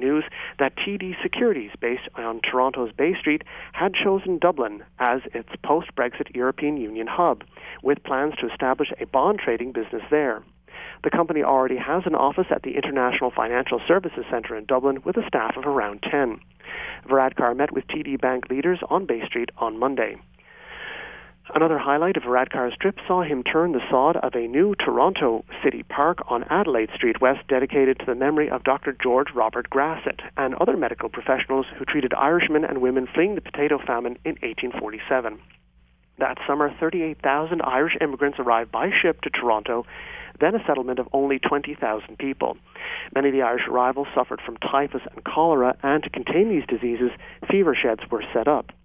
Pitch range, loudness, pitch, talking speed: 125-150 Hz, -23 LUFS, 135 Hz, 170 wpm